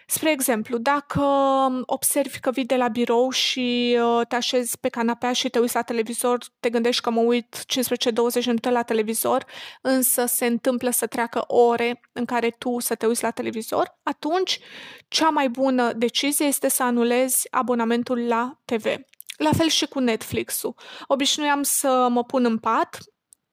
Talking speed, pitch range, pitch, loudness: 165 wpm, 235-270 Hz, 245 Hz, -22 LUFS